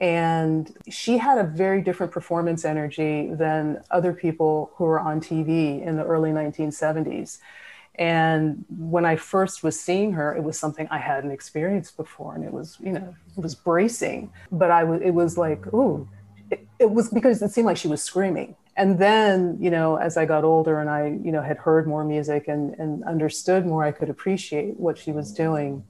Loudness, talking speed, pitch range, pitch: -23 LUFS, 195 wpm, 155-180 Hz, 160 Hz